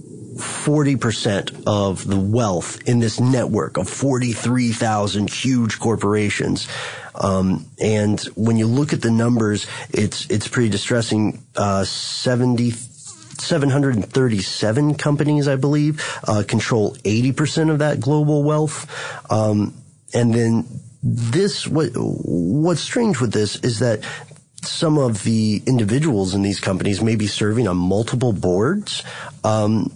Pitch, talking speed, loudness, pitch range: 120 Hz, 130 wpm, -19 LUFS, 105-140 Hz